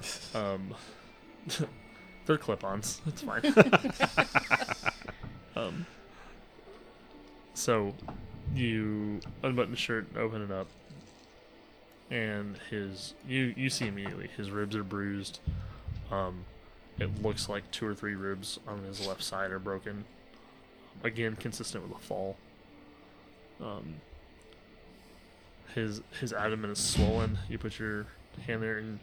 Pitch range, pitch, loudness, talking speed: 95-110 Hz, 105 Hz, -33 LUFS, 115 wpm